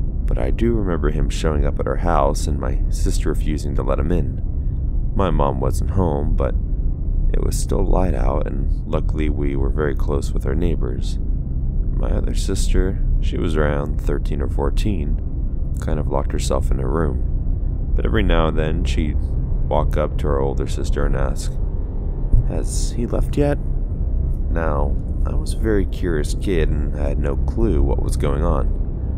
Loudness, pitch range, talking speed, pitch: -22 LUFS, 70-85 Hz, 175 wpm, 75 Hz